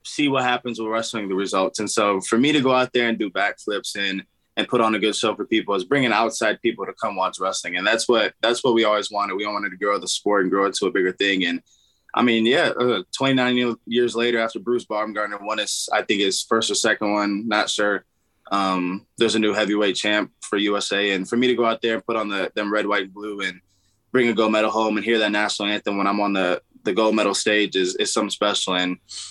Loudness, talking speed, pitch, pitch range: -21 LUFS, 260 wpm, 105 Hz, 100-115 Hz